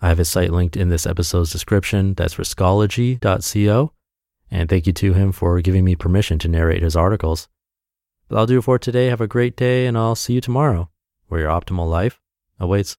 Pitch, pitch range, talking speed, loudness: 95 Hz, 85-110 Hz, 205 wpm, -18 LUFS